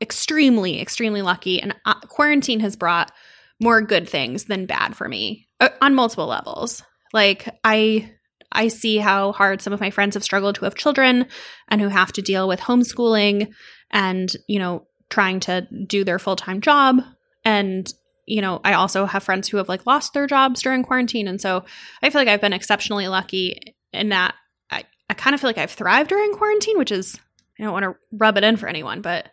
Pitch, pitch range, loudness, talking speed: 210 Hz, 190-245 Hz, -19 LUFS, 195 wpm